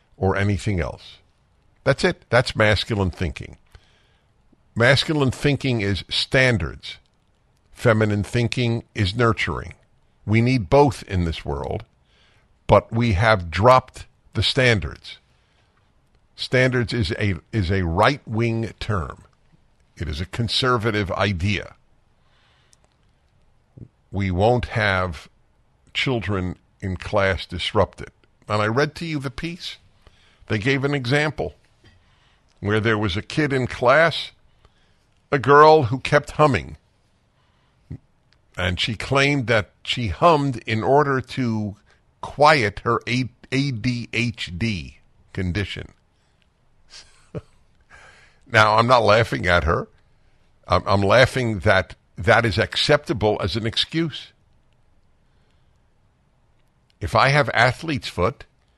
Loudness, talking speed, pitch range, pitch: -20 LUFS, 105 wpm, 95-125 Hz, 110 Hz